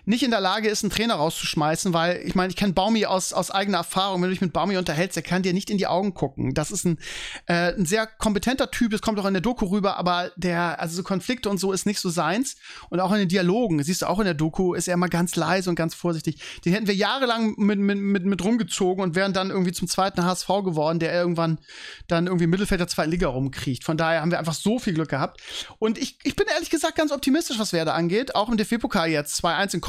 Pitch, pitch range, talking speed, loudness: 185 Hz, 175-210 Hz, 260 wpm, -24 LUFS